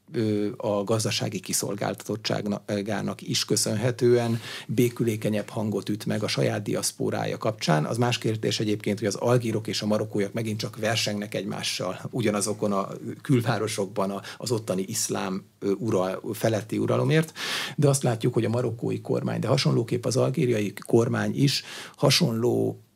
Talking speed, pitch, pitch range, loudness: 130 wpm, 110 Hz, 105-120 Hz, -26 LUFS